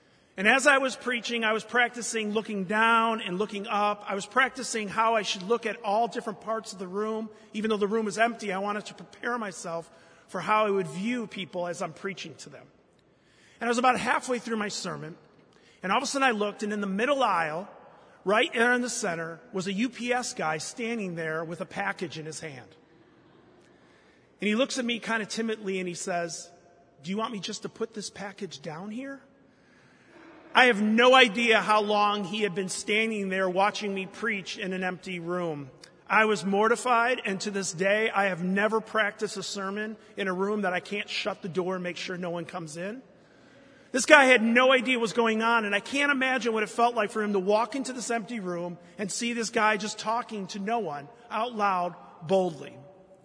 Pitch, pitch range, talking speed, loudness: 210 Hz, 190-230 Hz, 215 wpm, -27 LUFS